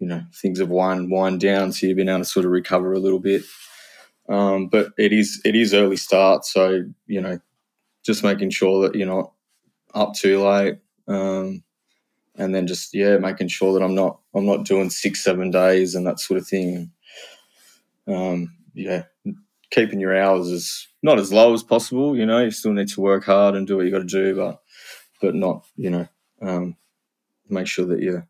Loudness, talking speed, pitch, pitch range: -20 LUFS, 200 wpm, 95 Hz, 95-100 Hz